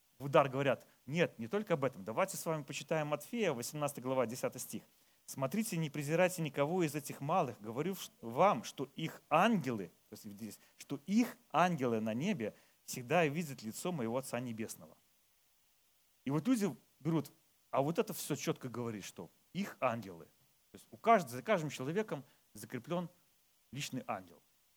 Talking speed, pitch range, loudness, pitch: 150 wpm, 130-175 Hz, -37 LUFS, 150 Hz